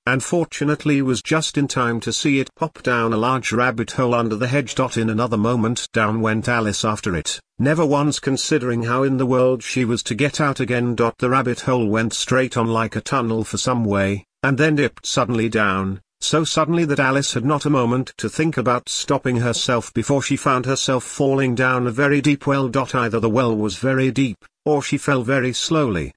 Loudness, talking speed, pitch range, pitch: -19 LUFS, 200 wpm, 115-140 Hz, 125 Hz